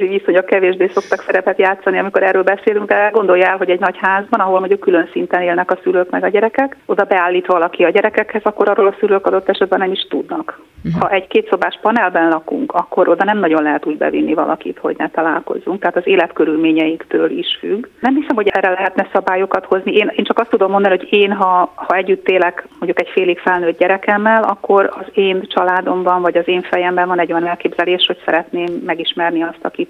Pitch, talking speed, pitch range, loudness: 190 Hz, 205 wpm, 180-210 Hz, -14 LUFS